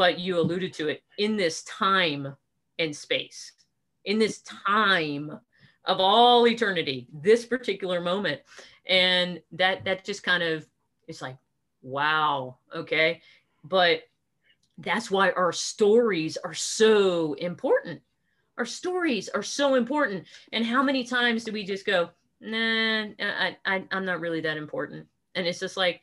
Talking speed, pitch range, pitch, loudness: 145 wpm, 165-220 Hz, 185 Hz, -25 LUFS